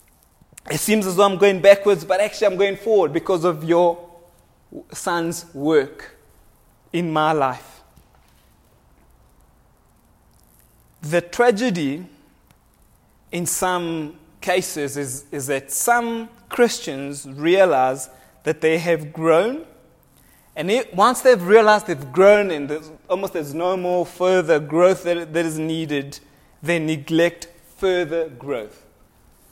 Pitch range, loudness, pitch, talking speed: 145-185 Hz, -19 LUFS, 170 Hz, 120 wpm